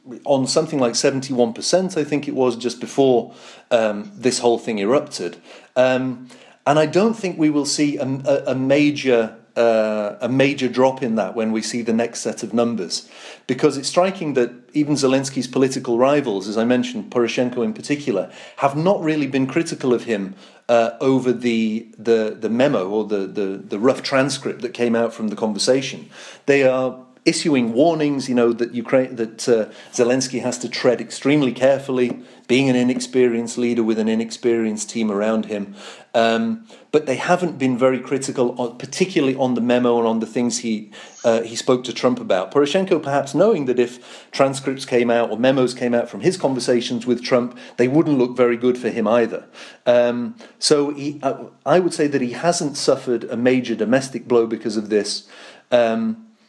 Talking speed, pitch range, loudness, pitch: 185 wpm, 115-135 Hz, -20 LUFS, 125 Hz